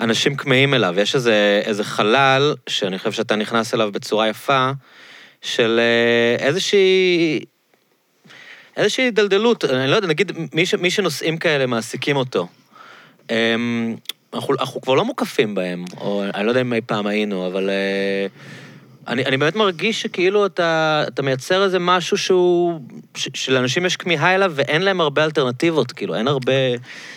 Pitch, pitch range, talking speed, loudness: 135 Hz, 115-180 Hz, 150 wpm, -18 LUFS